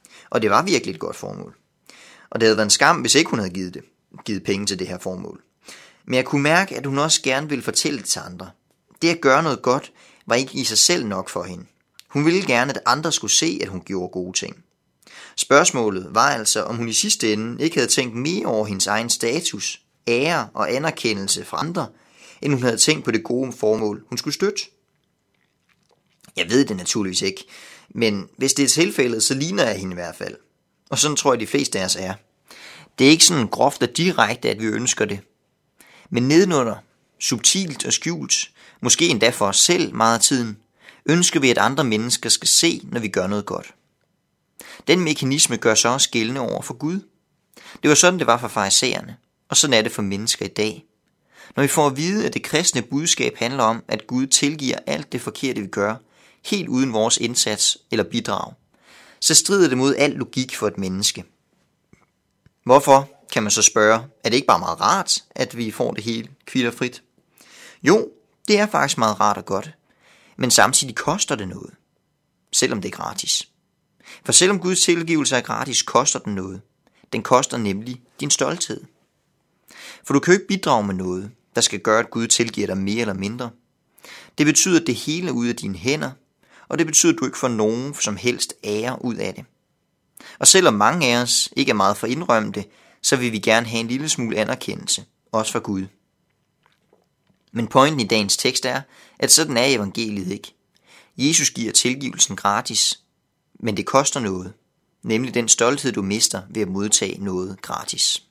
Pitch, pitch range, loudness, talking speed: 120 Hz, 105-145 Hz, -19 LUFS, 195 wpm